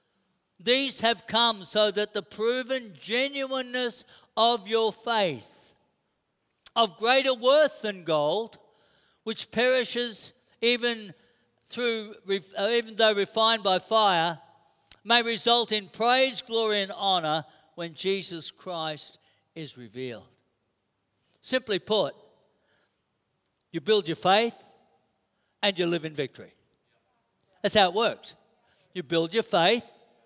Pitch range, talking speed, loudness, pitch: 170-235 Hz, 110 wpm, -25 LUFS, 215 Hz